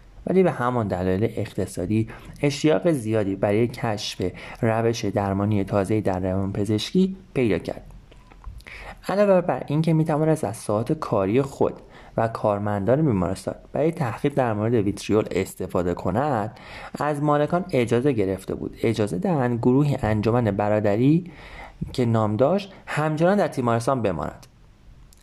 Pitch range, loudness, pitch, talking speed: 105-145 Hz, -23 LUFS, 115 Hz, 125 wpm